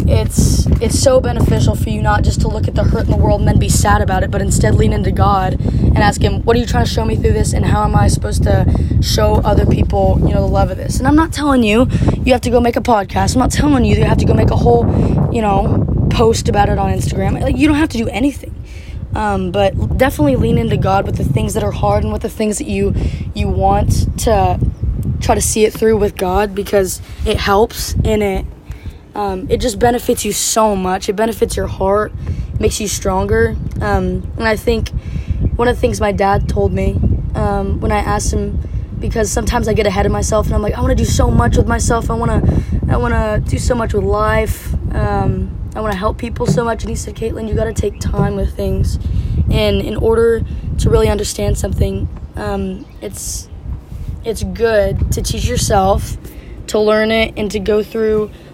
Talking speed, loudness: 230 wpm, -15 LUFS